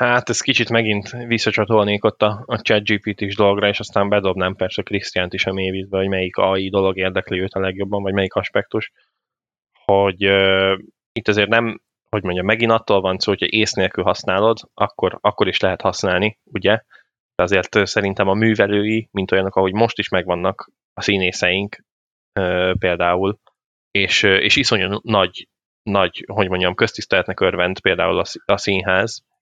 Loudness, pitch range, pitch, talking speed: -18 LUFS, 95-110 Hz, 100 Hz, 165 wpm